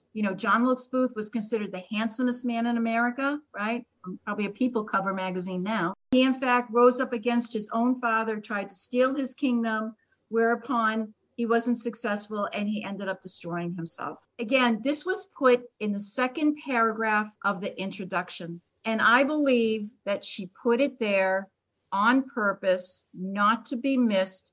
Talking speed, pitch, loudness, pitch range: 165 wpm, 225 Hz, -27 LUFS, 200-245 Hz